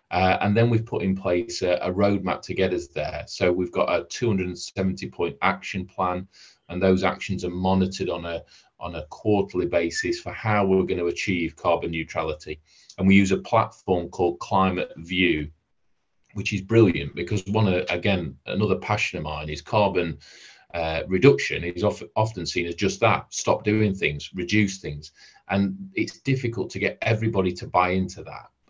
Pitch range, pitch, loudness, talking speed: 90-105 Hz, 95 Hz, -24 LUFS, 180 wpm